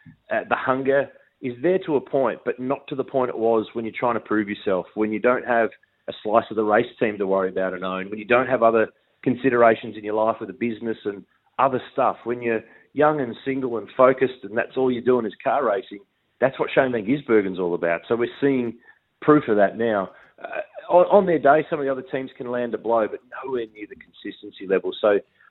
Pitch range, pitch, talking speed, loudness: 110-130 Hz, 120 Hz, 240 wpm, -22 LUFS